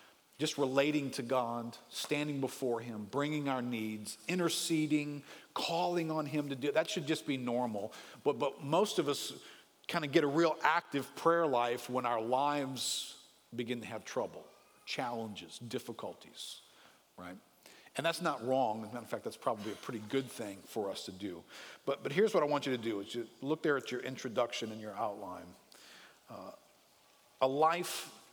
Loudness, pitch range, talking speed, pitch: -35 LUFS, 120-150 Hz, 180 wpm, 130 Hz